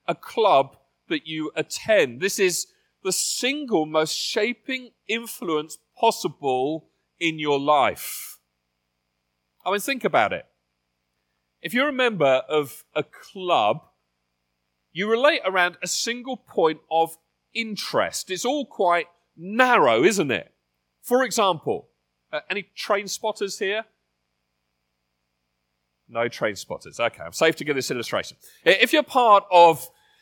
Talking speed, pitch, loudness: 125 wpm, 160 Hz, -23 LUFS